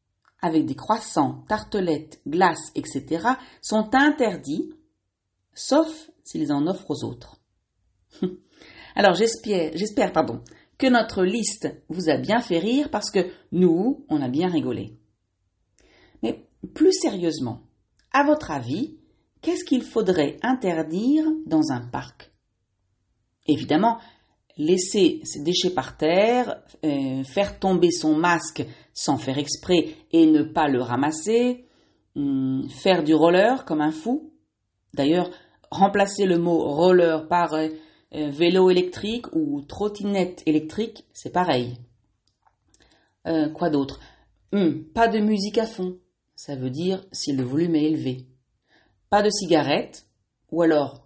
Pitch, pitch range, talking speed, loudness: 175 Hz, 150-225 Hz, 125 wpm, -23 LUFS